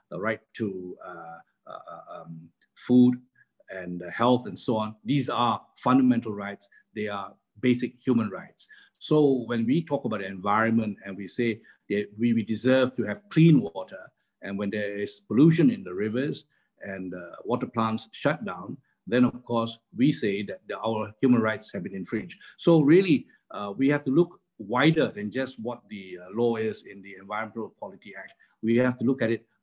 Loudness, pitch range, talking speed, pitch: -26 LUFS, 100-125 Hz, 190 wpm, 115 Hz